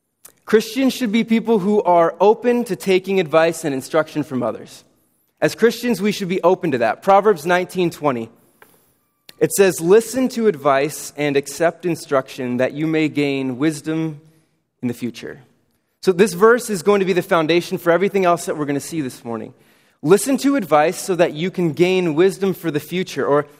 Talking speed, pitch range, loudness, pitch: 185 wpm, 150-200 Hz, -18 LUFS, 175 Hz